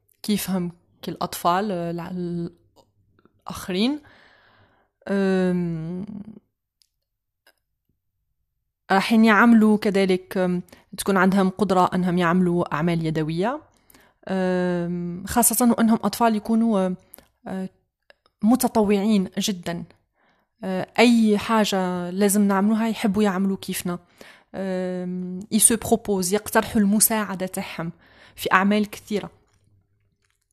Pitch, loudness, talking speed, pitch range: 190 Hz, -21 LUFS, 75 wpm, 175-210 Hz